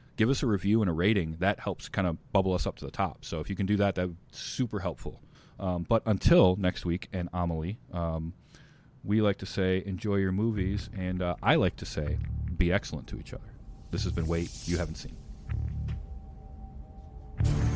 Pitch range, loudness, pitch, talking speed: 85-105 Hz, -30 LUFS, 95 Hz, 200 wpm